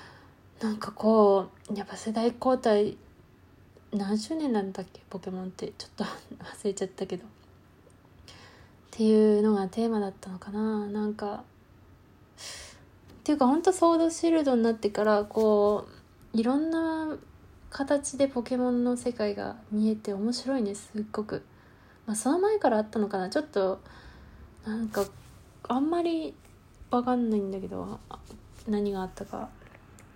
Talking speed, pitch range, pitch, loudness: 285 characters per minute, 200-245 Hz, 215 Hz, -28 LUFS